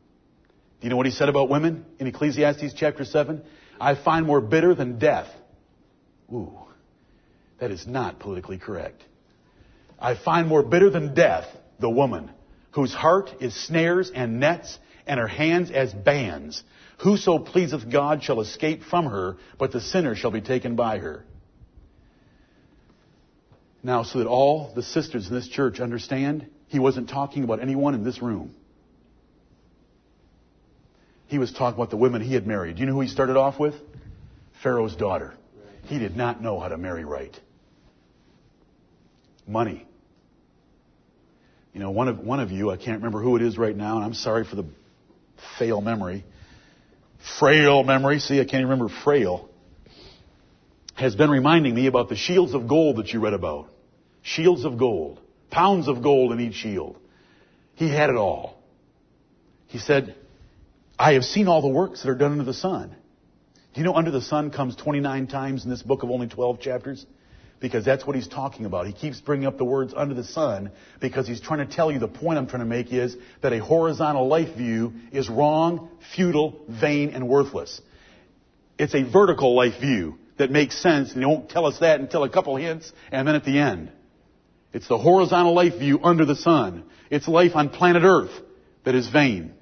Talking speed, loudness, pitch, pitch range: 180 wpm, -23 LUFS, 135 Hz, 120-150 Hz